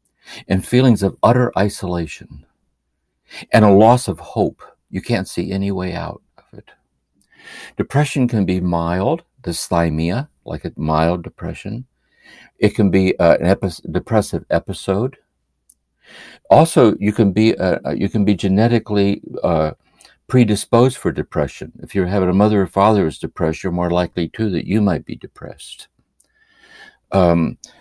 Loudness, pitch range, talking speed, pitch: -17 LUFS, 85-110 Hz, 140 wpm, 95 Hz